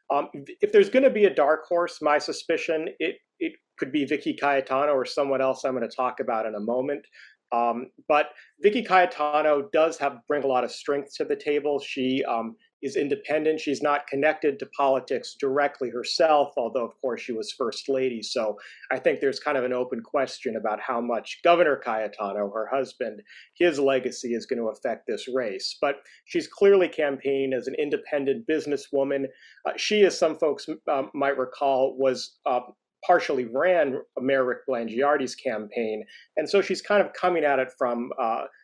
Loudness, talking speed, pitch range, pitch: -25 LUFS, 185 wpm, 130-175 Hz, 145 Hz